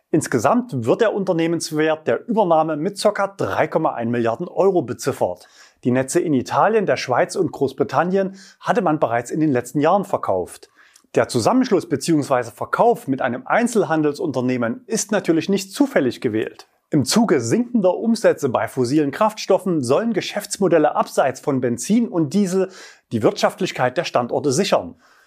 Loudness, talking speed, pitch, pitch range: -20 LUFS, 140 wpm, 170 Hz, 140-205 Hz